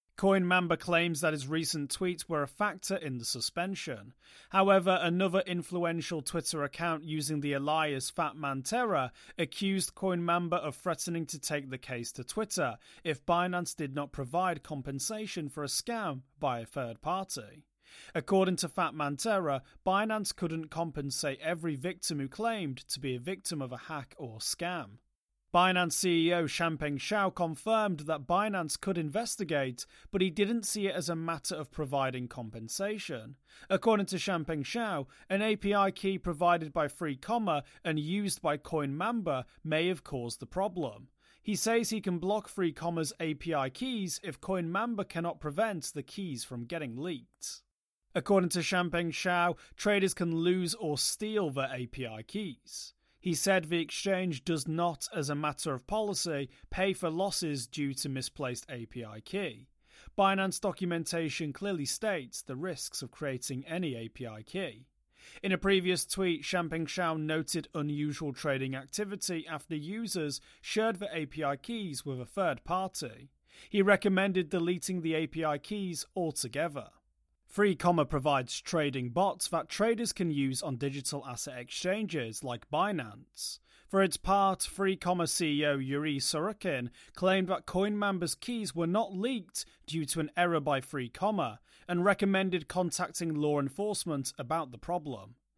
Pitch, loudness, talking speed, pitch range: 165 Hz, -32 LUFS, 145 wpm, 145-190 Hz